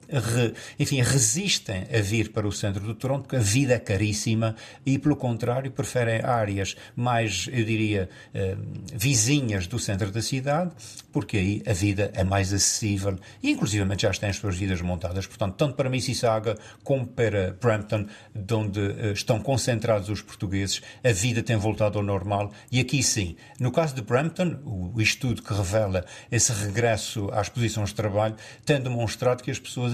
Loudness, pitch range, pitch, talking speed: -26 LUFS, 105-125 Hz, 110 Hz, 170 wpm